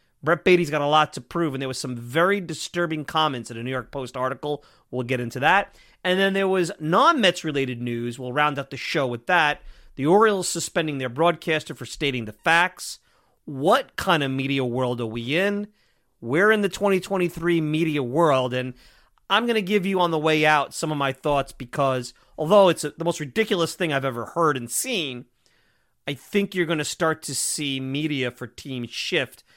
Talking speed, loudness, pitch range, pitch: 205 wpm, -23 LUFS, 130-175 Hz, 150 Hz